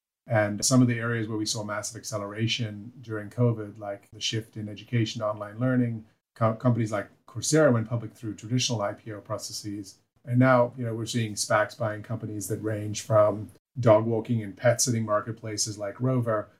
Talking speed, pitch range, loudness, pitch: 180 wpm, 105-120 Hz, -27 LUFS, 110 Hz